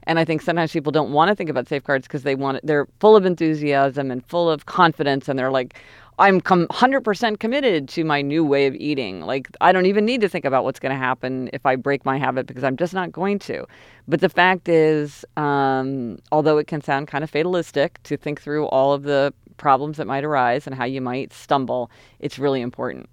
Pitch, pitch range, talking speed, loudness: 145 Hz, 135-165 Hz, 225 wpm, -20 LUFS